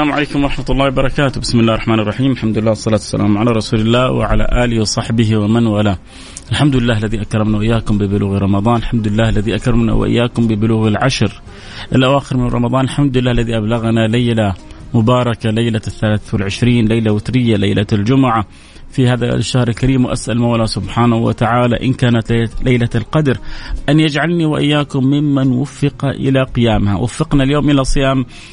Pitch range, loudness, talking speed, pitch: 110-130 Hz, -14 LUFS, 155 wpm, 115 Hz